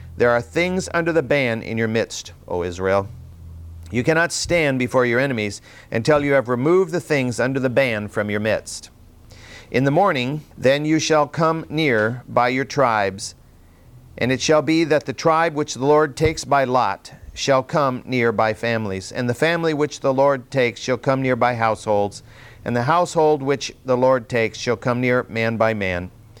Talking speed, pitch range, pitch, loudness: 190 wpm, 115-150 Hz, 125 Hz, -20 LUFS